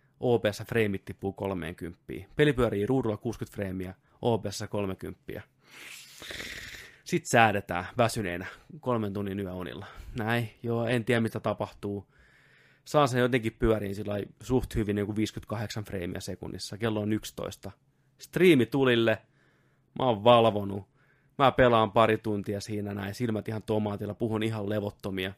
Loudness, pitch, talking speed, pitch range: -29 LUFS, 110 Hz, 130 wpm, 100-120 Hz